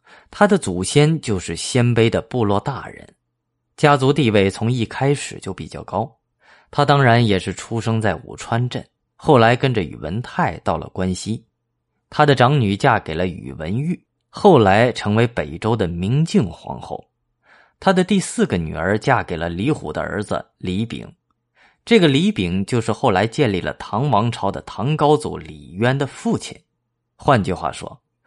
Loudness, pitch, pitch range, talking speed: -19 LUFS, 115 Hz, 95-140 Hz, 240 characters per minute